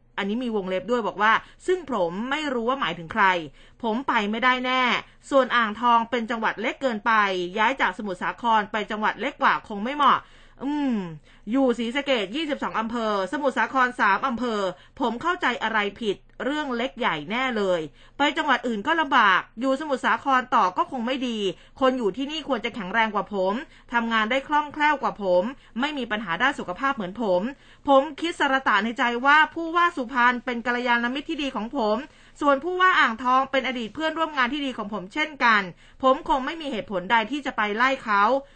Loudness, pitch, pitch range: -24 LUFS, 245 Hz, 215-275 Hz